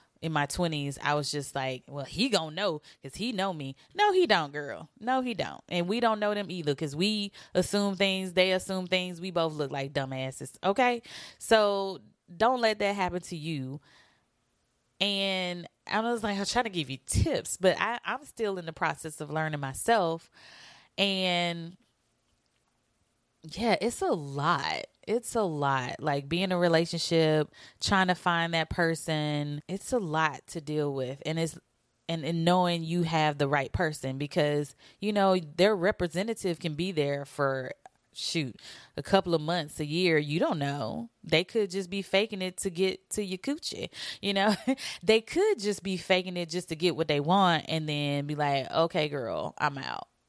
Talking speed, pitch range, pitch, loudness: 185 wpm, 150-195 Hz, 170 Hz, -29 LUFS